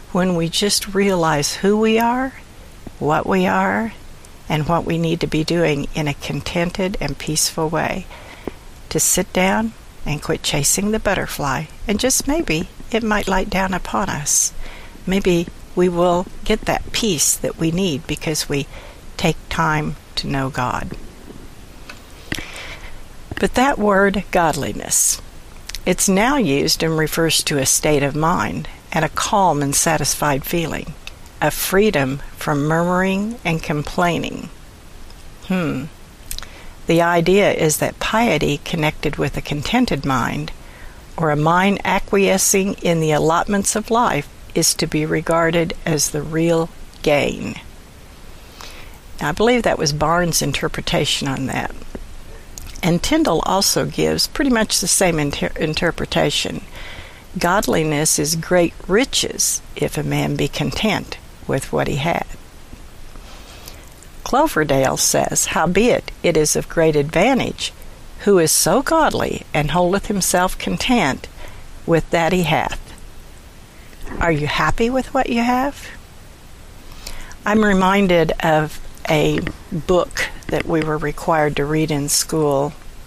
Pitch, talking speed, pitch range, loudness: 165 Hz, 130 wpm, 145-195 Hz, -18 LUFS